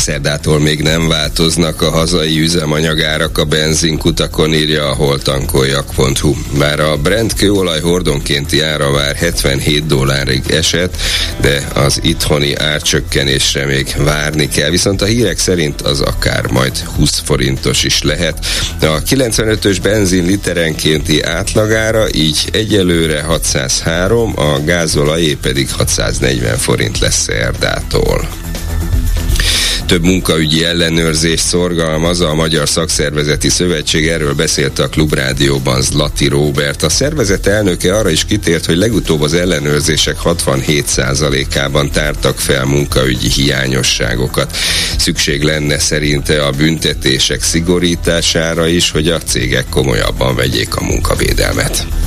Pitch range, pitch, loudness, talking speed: 75-85 Hz, 80 Hz, -12 LUFS, 115 wpm